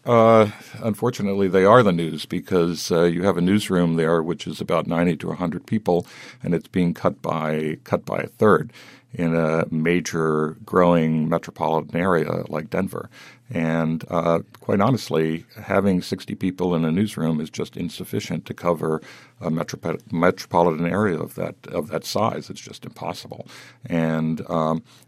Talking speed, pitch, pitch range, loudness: 165 wpm, 85 Hz, 80-95 Hz, -22 LUFS